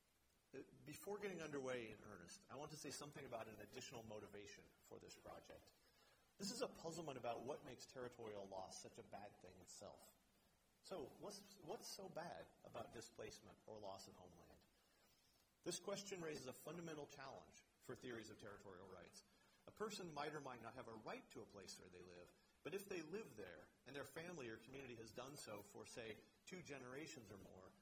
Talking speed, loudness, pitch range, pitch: 190 wpm, -56 LUFS, 105-150 Hz, 125 Hz